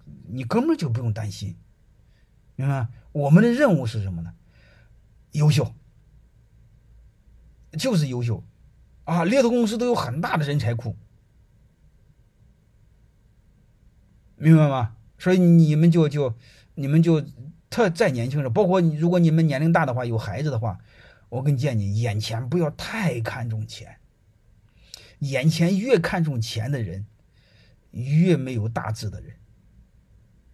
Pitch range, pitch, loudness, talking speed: 110-160 Hz, 125 Hz, -22 LUFS, 200 characters per minute